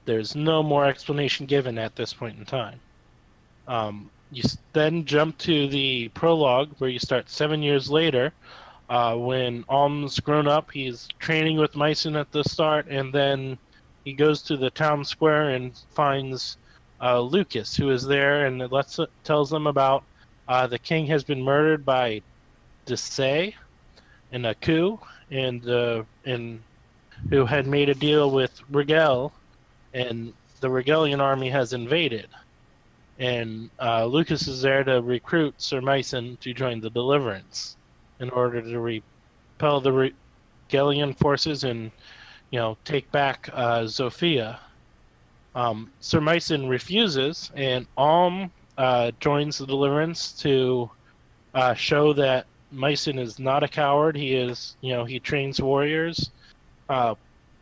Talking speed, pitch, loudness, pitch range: 145 wpm, 135 Hz, -24 LUFS, 120-150 Hz